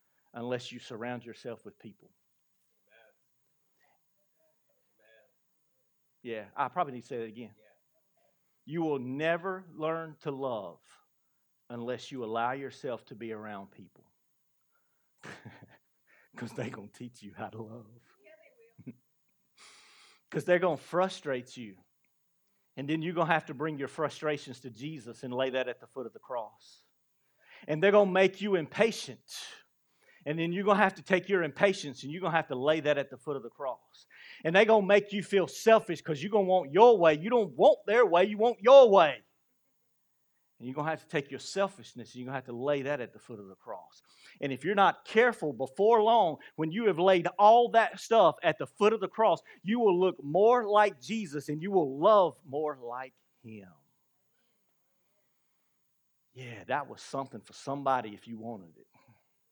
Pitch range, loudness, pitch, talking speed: 125-195 Hz, -28 LUFS, 155 Hz, 185 wpm